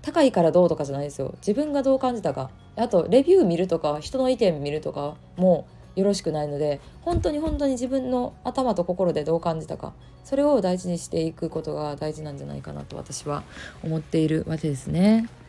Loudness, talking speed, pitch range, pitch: -24 LUFS, 430 characters per minute, 155-250 Hz, 170 Hz